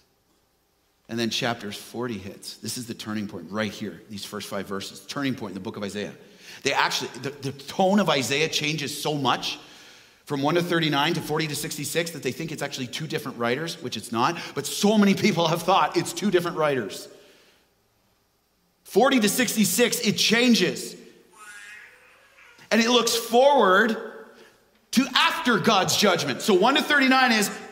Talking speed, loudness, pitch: 175 wpm, -23 LUFS, 155 Hz